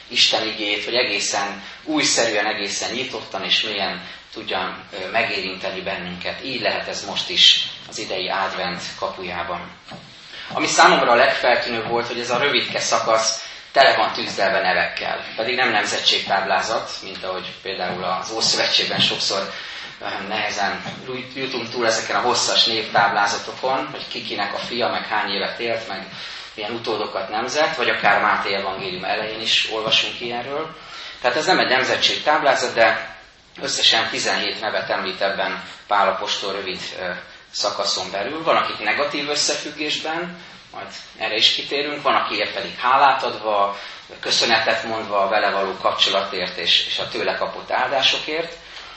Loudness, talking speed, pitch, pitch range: -20 LUFS, 135 wpm, 110 Hz, 100-125 Hz